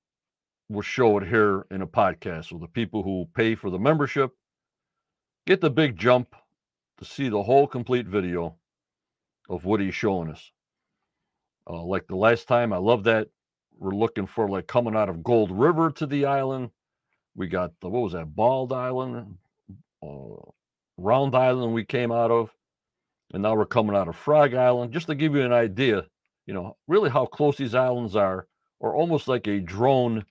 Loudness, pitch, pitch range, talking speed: -24 LUFS, 115 Hz, 100-130 Hz, 180 wpm